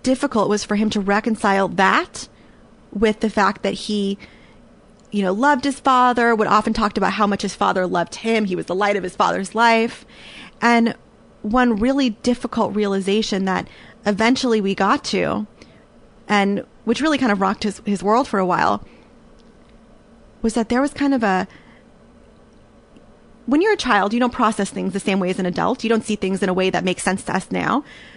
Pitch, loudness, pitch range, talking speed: 215 Hz, -19 LUFS, 200-235 Hz, 195 wpm